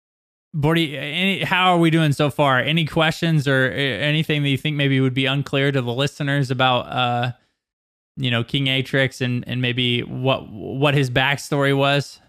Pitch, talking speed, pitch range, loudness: 140 Hz, 170 wpm, 130-150 Hz, -19 LUFS